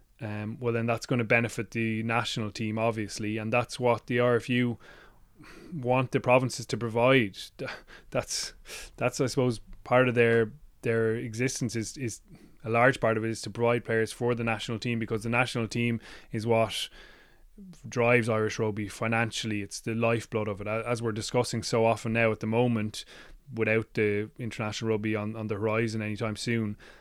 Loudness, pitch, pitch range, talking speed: -28 LUFS, 115 Hz, 110-120 Hz, 175 wpm